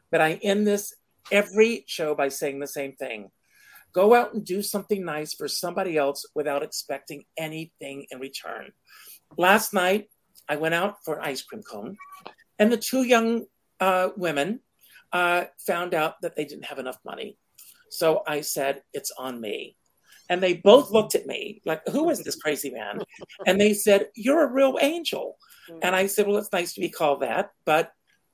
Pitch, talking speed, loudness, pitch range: 185 Hz, 180 wpm, -24 LUFS, 155-210 Hz